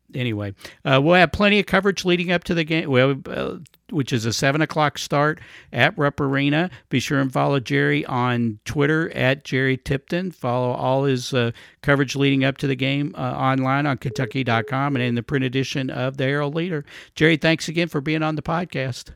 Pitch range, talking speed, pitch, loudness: 130-155 Hz, 200 wpm, 140 Hz, -21 LUFS